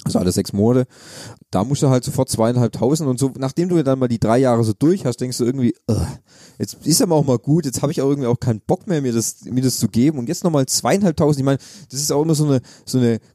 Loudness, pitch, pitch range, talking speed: -18 LUFS, 130 Hz, 120-145 Hz, 270 wpm